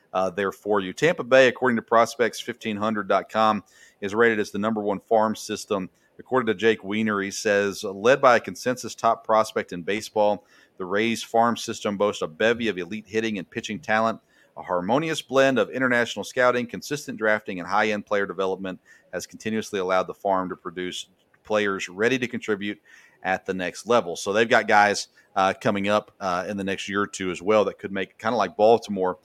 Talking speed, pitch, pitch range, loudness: 195 wpm, 105 Hz, 95-115 Hz, -24 LUFS